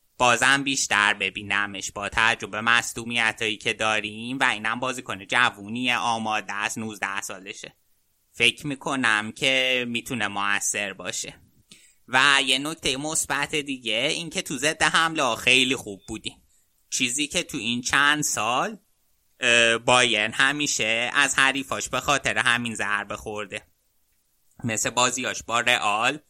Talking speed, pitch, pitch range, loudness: 130 wpm, 120 Hz, 105-135 Hz, -22 LUFS